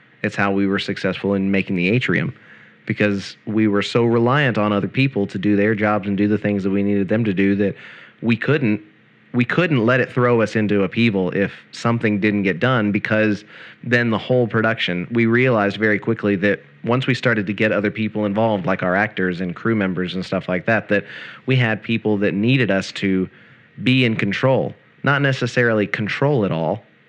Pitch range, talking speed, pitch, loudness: 100-115 Hz, 200 wpm, 105 Hz, -19 LUFS